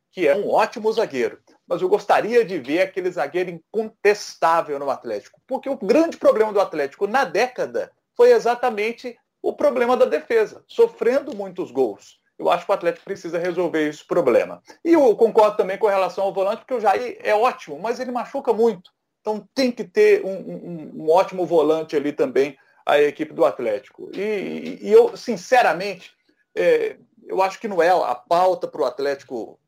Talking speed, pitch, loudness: 180 wpm, 225 Hz, -21 LUFS